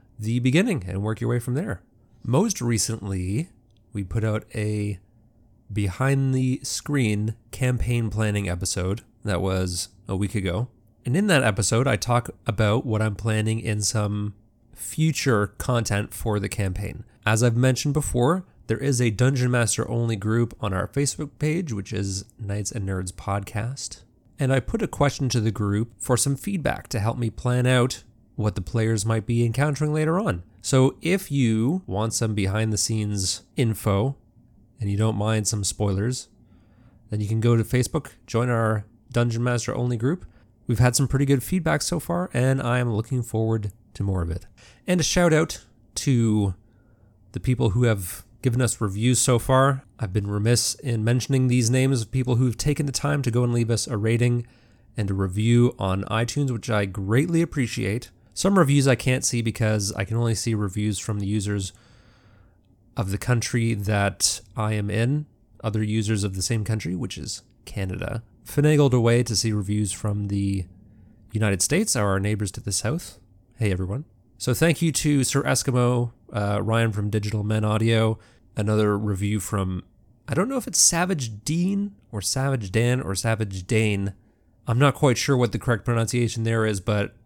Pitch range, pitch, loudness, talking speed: 105-125 Hz, 115 Hz, -24 LUFS, 175 wpm